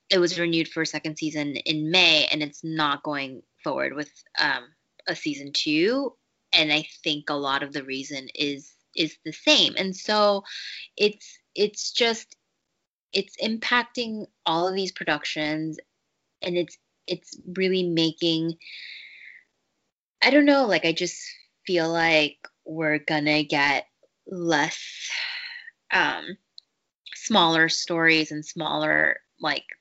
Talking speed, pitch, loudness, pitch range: 130 wpm, 165 Hz, -24 LUFS, 150-195 Hz